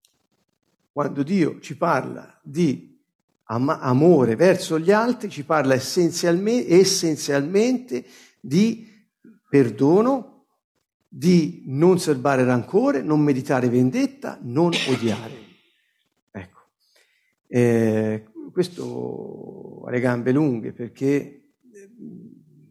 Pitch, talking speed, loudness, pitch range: 155 Hz, 85 wpm, -21 LUFS, 130-200 Hz